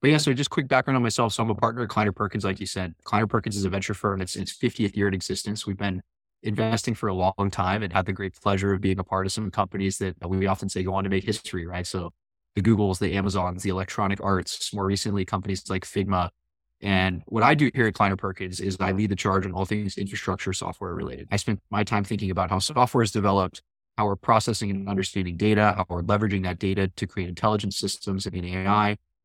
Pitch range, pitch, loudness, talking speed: 95-105 Hz, 100 Hz, -26 LUFS, 245 wpm